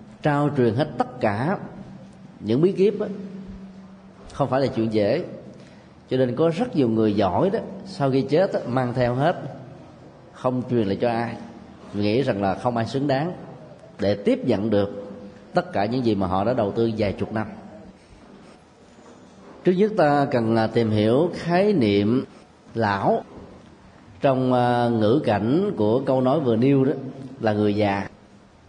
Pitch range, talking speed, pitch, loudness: 110-145 Hz, 165 wpm, 125 Hz, -22 LUFS